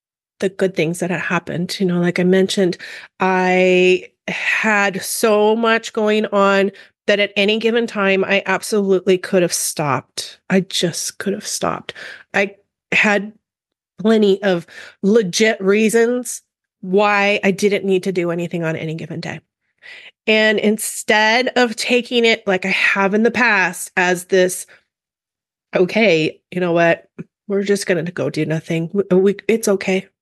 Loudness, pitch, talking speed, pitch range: -17 LUFS, 195 Hz, 150 wpm, 180-210 Hz